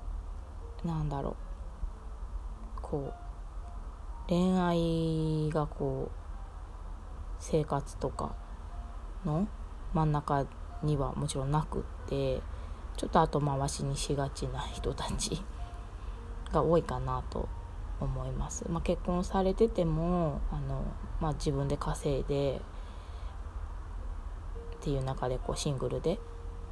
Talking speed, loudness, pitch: 195 characters per minute, -34 LUFS, 85 Hz